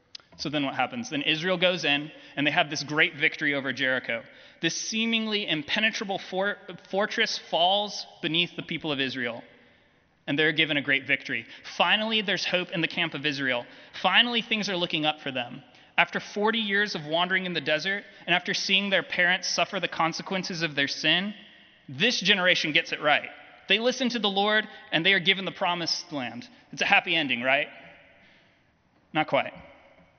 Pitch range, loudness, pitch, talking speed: 155-200 Hz, -25 LUFS, 175 Hz, 180 wpm